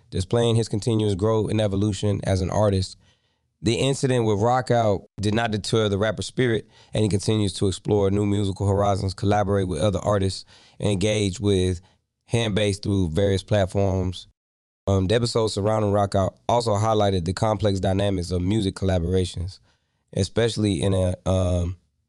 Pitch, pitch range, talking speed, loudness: 100 Hz, 95-110 Hz, 150 wpm, -23 LUFS